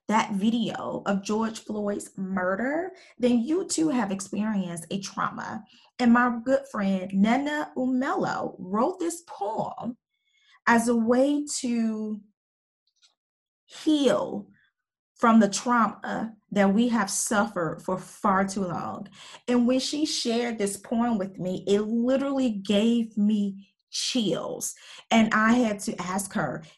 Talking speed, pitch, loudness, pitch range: 130 wpm, 225 Hz, -26 LUFS, 200-250 Hz